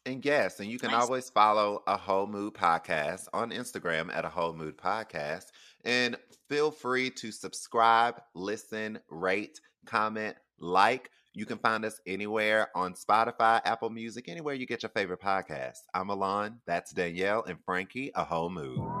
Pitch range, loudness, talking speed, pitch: 95-120 Hz, -30 LUFS, 160 wpm, 110 Hz